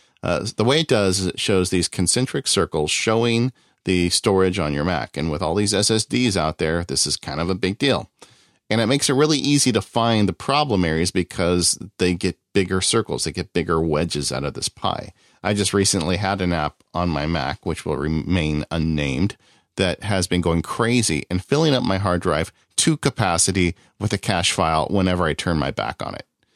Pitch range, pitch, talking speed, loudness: 85-105 Hz, 95 Hz, 210 wpm, -21 LUFS